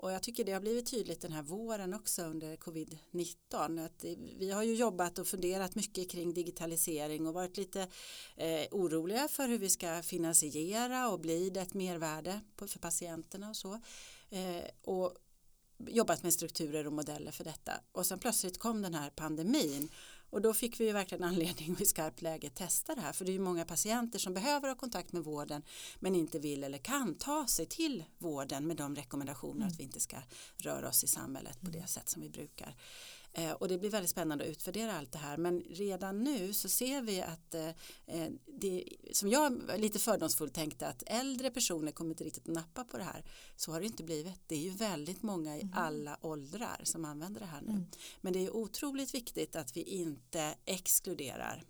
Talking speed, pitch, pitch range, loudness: 195 wpm, 180 Hz, 160-210 Hz, -37 LUFS